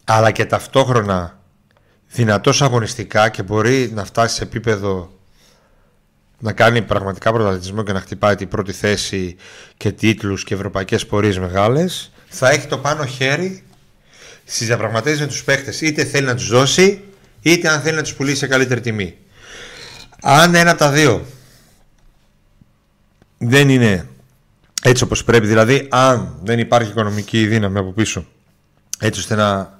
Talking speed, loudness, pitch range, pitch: 145 wpm, -16 LUFS, 100-135 Hz, 115 Hz